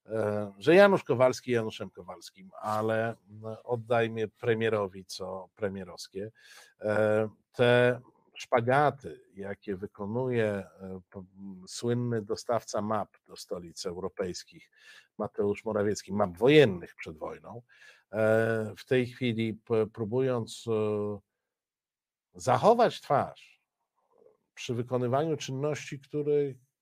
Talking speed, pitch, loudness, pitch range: 80 wpm, 110 Hz, -29 LUFS, 105-125 Hz